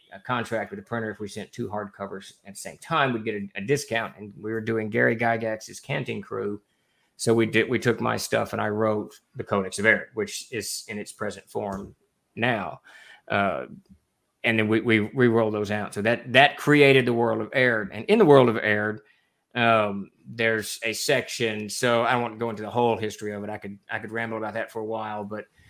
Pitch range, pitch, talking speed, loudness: 105-120 Hz, 110 Hz, 230 wpm, -24 LUFS